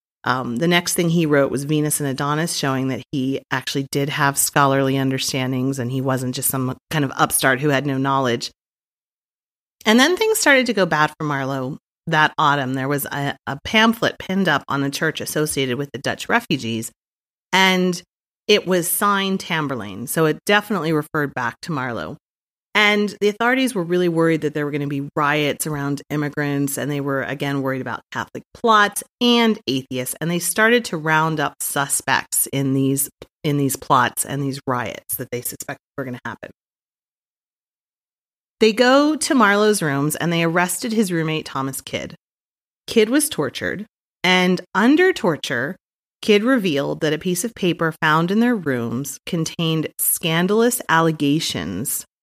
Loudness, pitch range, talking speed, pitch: -19 LUFS, 135-185 Hz, 170 wpm, 150 Hz